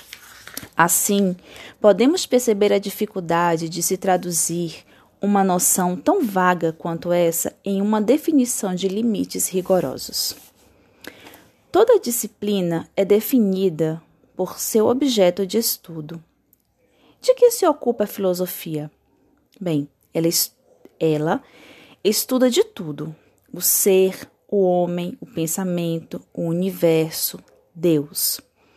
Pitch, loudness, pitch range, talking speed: 185 Hz, -20 LUFS, 170-215 Hz, 105 wpm